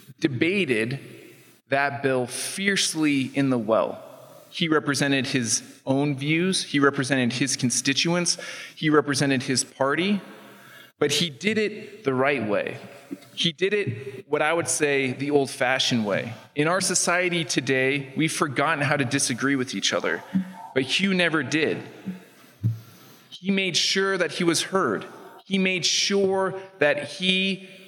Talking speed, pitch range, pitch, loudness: 140 wpm, 135-185 Hz, 145 Hz, -23 LUFS